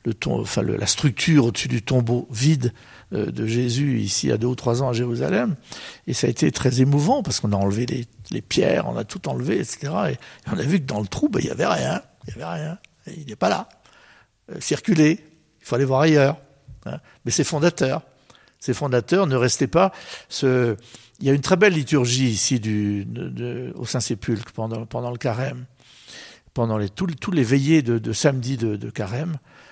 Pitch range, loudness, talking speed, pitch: 120-145 Hz, -22 LUFS, 215 wpm, 125 Hz